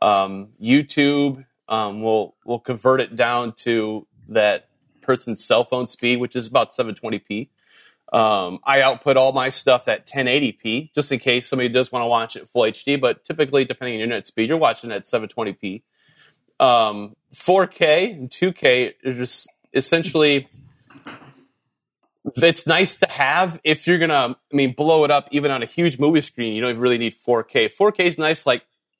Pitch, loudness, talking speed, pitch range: 130 Hz, -19 LUFS, 170 wpm, 120-150 Hz